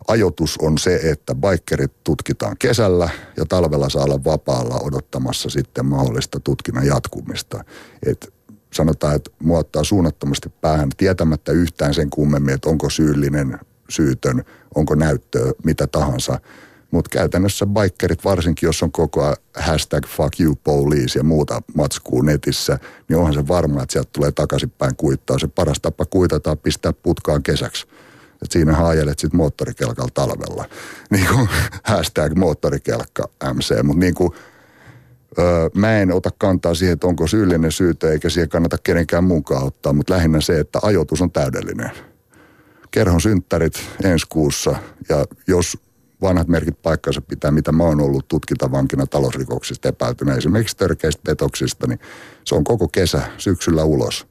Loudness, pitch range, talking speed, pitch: -18 LUFS, 75-90 Hz, 145 wpm, 80 Hz